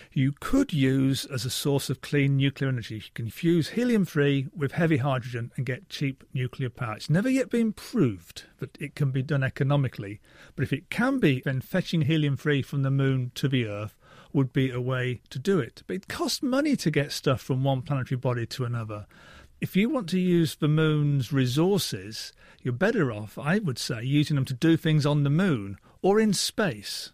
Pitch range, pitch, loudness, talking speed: 130-160 Hz, 140 Hz, -26 LUFS, 205 wpm